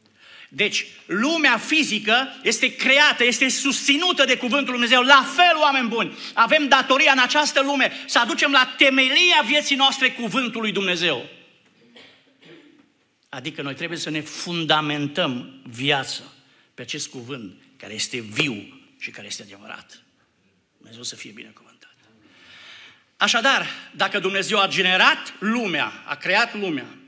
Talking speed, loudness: 130 wpm, -19 LUFS